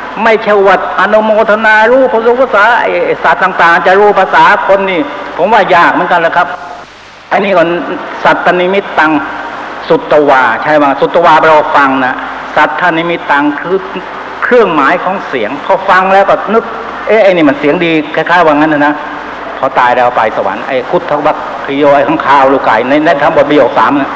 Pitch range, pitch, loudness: 150-200 Hz, 175 Hz, -8 LUFS